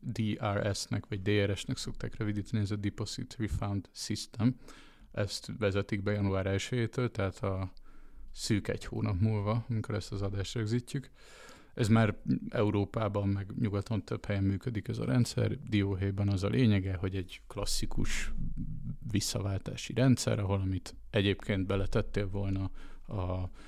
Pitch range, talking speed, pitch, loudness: 100-115 Hz, 130 wpm, 105 Hz, -33 LUFS